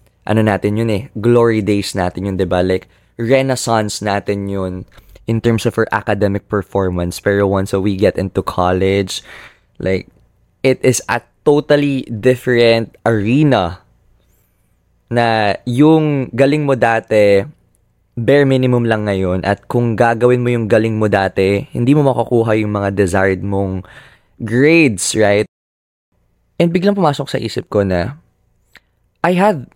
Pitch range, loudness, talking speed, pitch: 95-125 Hz, -15 LUFS, 140 wpm, 110 Hz